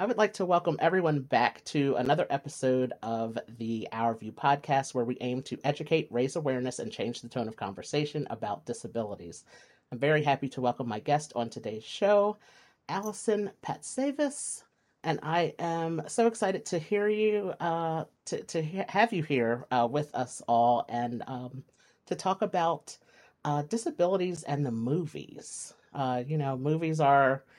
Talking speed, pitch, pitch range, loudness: 165 wpm, 145 Hz, 125-175 Hz, -30 LUFS